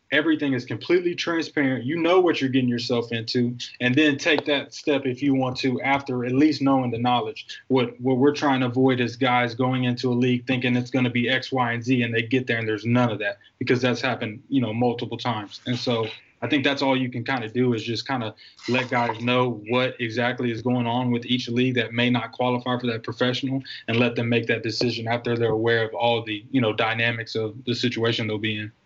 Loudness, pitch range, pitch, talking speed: -23 LUFS, 120-130 Hz, 125 Hz, 245 wpm